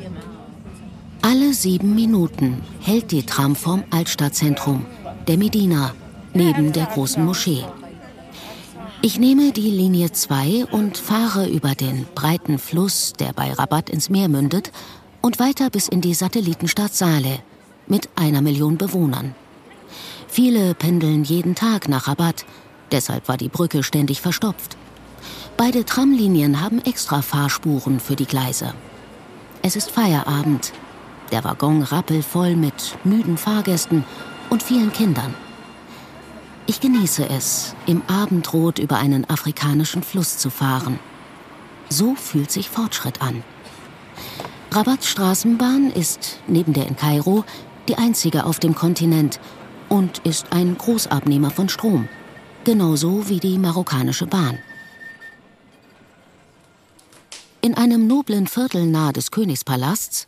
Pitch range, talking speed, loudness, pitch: 145-210 Hz, 120 wpm, -19 LUFS, 170 Hz